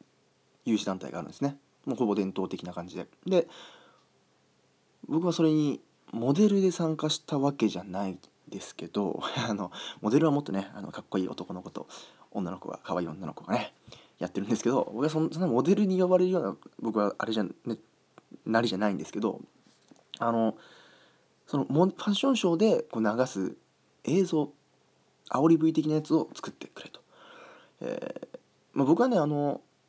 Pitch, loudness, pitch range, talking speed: 140 Hz, -29 LUFS, 100-160 Hz, 335 characters per minute